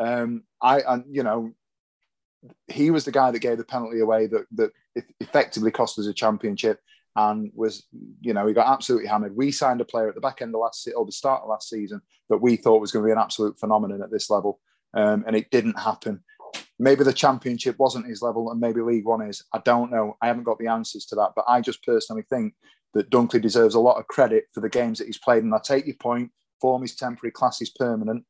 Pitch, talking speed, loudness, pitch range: 115 Hz, 240 wpm, -23 LUFS, 110-130 Hz